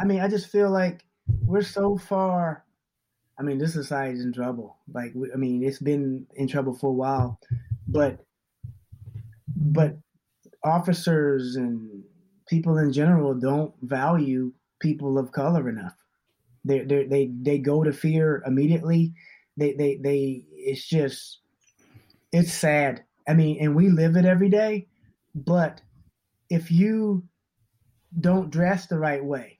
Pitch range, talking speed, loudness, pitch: 130-170 Hz, 145 wpm, -24 LUFS, 145 Hz